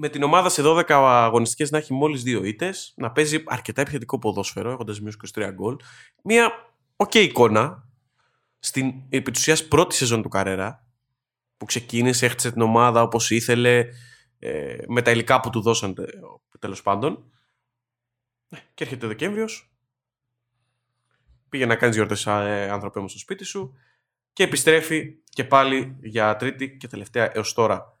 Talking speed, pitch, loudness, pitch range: 150 wpm, 125 Hz, -21 LUFS, 115-145 Hz